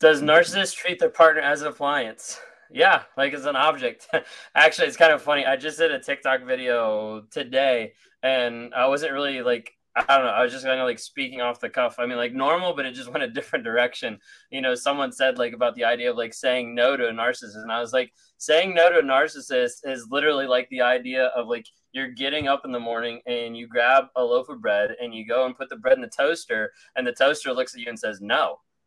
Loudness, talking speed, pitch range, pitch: -23 LUFS, 245 wpm, 120-145 Hz, 130 Hz